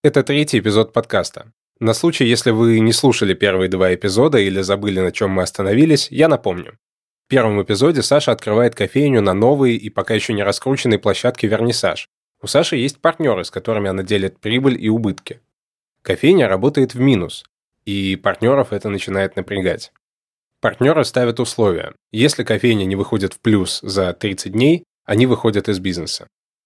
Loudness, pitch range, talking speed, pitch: -17 LUFS, 100-125 Hz, 160 wpm, 110 Hz